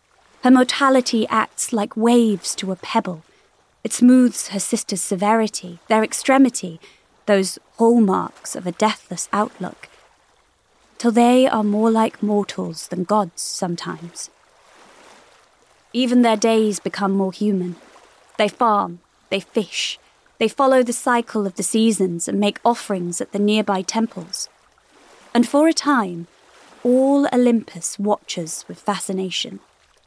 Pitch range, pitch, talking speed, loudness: 190-235 Hz, 215 Hz, 125 wpm, -19 LUFS